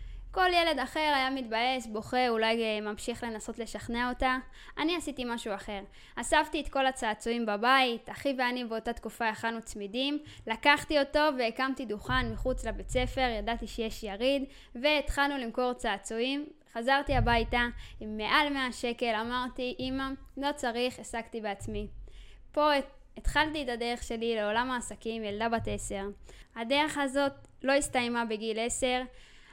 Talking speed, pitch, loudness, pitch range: 135 wpm, 245 Hz, -31 LUFS, 225-270 Hz